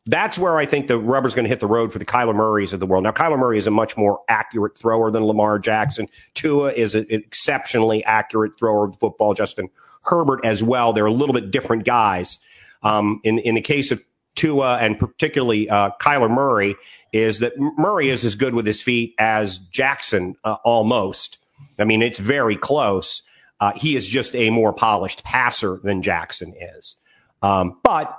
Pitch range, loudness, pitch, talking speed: 105-125 Hz, -19 LUFS, 110 Hz, 200 wpm